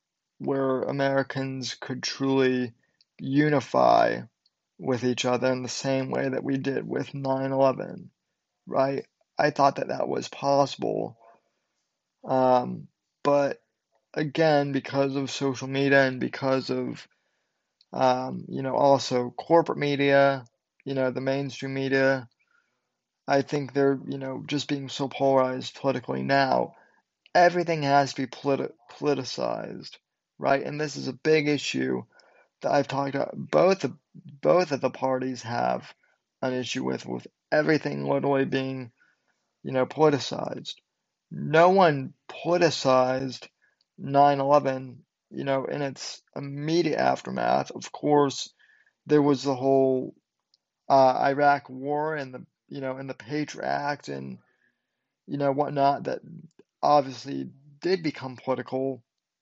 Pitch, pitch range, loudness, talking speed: 135 Hz, 130-145 Hz, -26 LUFS, 125 wpm